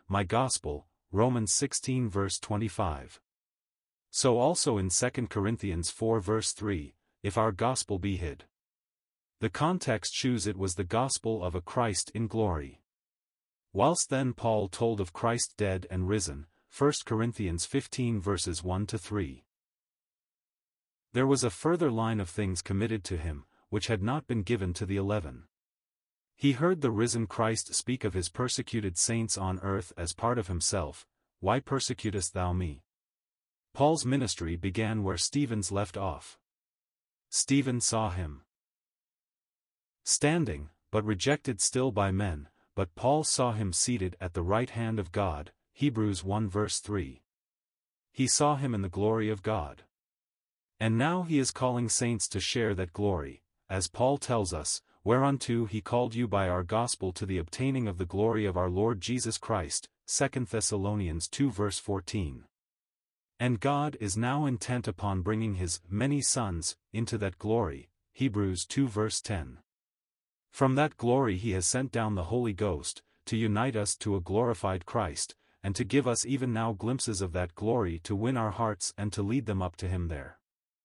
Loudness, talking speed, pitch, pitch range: -30 LUFS, 155 wpm, 105 Hz, 95-120 Hz